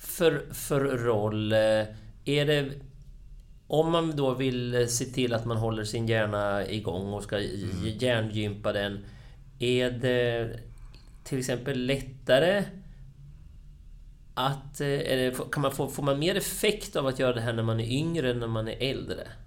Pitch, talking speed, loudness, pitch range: 125 Hz, 150 wpm, -28 LUFS, 110-140 Hz